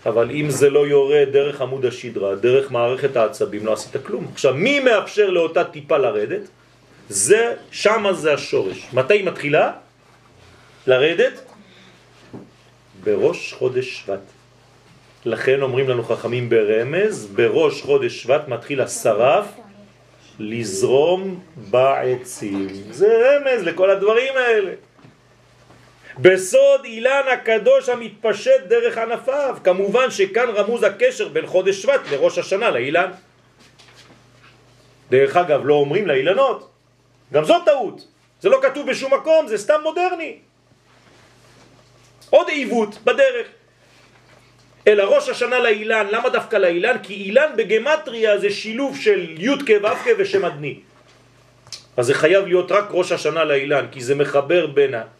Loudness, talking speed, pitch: -18 LUFS, 120 wpm, 230 Hz